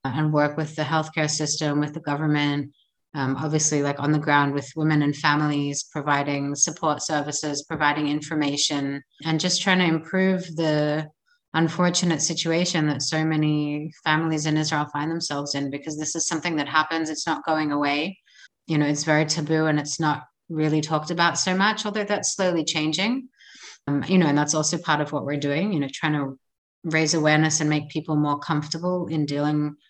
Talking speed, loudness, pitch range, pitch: 185 wpm, -23 LUFS, 145-160 Hz, 155 Hz